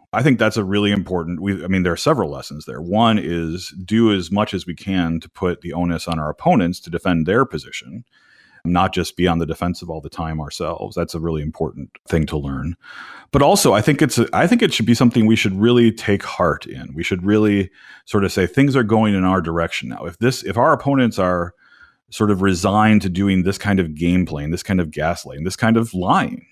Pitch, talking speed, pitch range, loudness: 95 Hz, 240 wpm, 85-105 Hz, -18 LUFS